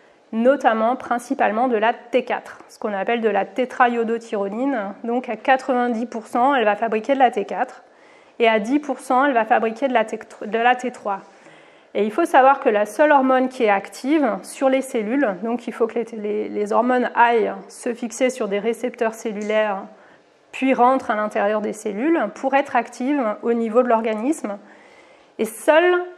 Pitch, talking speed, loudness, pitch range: 235 Hz, 165 wpm, -20 LUFS, 220-260 Hz